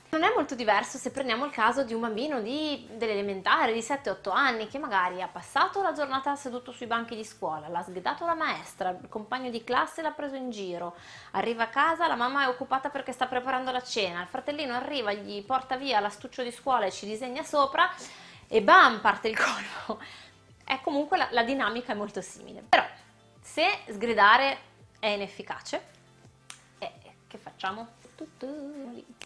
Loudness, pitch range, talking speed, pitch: -28 LUFS, 215-280 Hz, 180 wpm, 250 Hz